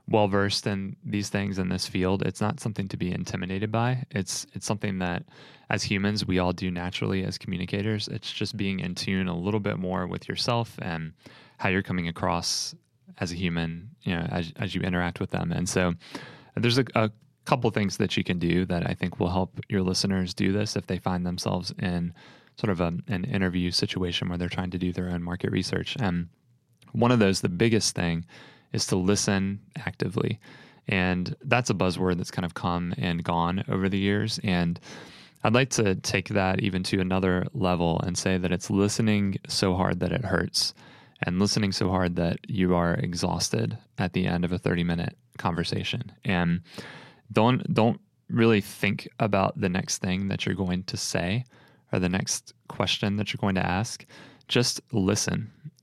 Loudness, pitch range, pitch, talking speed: -27 LUFS, 90-105 Hz, 95 Hz, 195 wpm